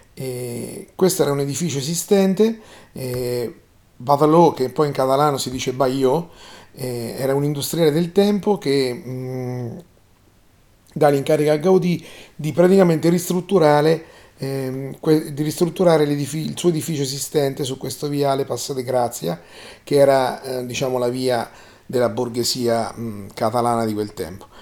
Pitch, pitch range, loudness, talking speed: 135 Hz, 125-155 Hz, -20 LUFS, 135 wpm